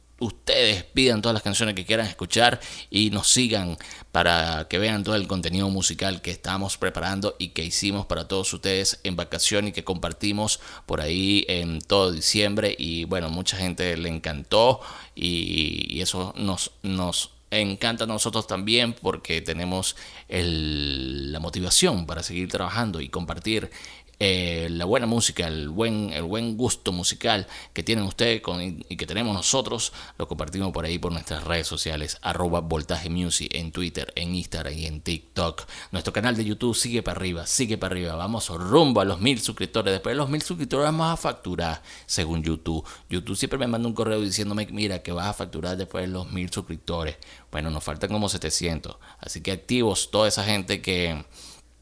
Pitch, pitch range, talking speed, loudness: 90 Hz, 85-105 Hz, 175 wpm, -25 LUFS